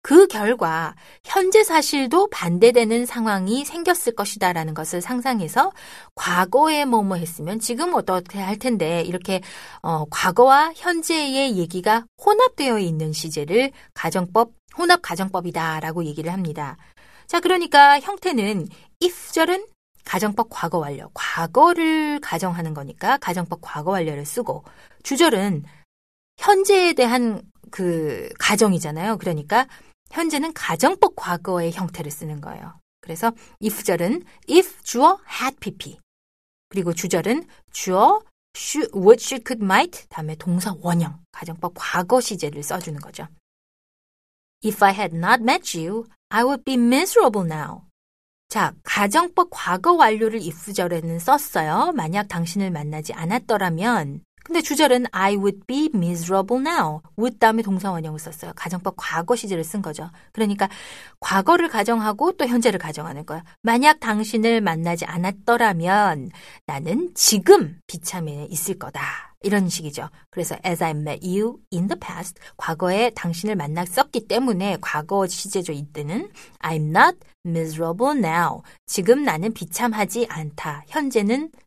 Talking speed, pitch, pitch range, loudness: 340 characters per minute, 205 Hz, 170-255 Hz, -21 LUFS